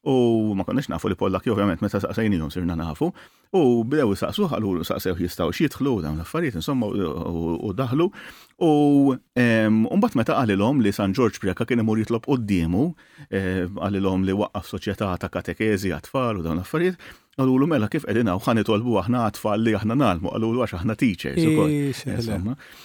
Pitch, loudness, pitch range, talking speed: 110 Hz, -23 LUFS, 95-130 Hz, 165 wpm